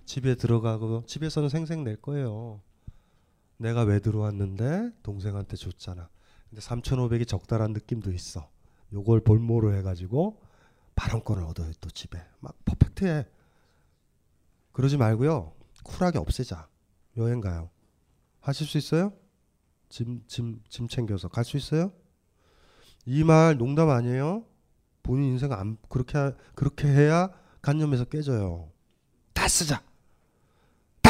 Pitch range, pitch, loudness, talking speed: 95-140 Hz, 115 Hz, -27 LUFS, 250 characters per minute